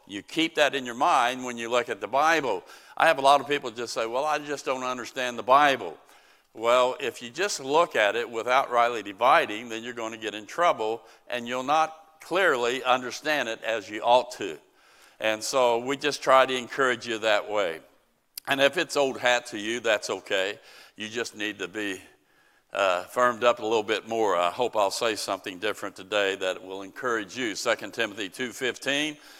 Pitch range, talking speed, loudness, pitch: 110-140 Hz, 205 wpm, -26 LUFS, 125 Hz